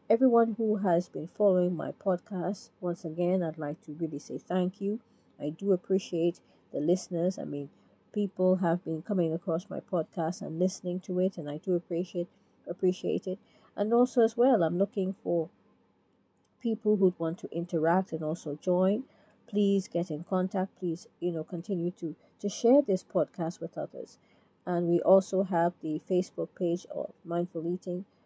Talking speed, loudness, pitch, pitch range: 170 wpm, -30 LUFS, 180 Hz, 170-195 Hz